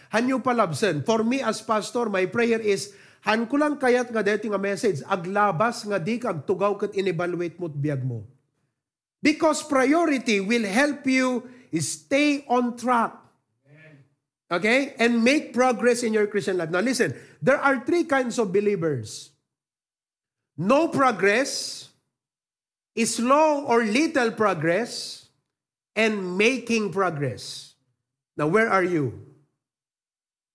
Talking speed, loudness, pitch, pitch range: 110 wpm, -23 LUFS, 210 Hz, 160-245 Hz